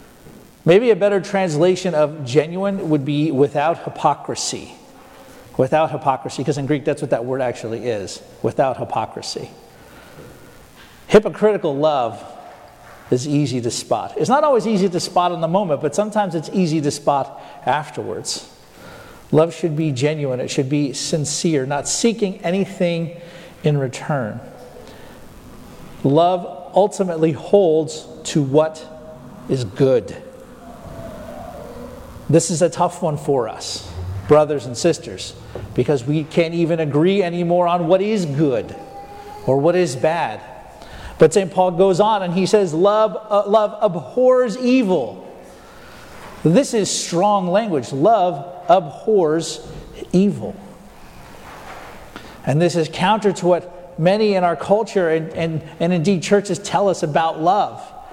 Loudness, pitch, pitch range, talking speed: -18 LUFS, 170 Hz, 150-195 Hz, 130 wpm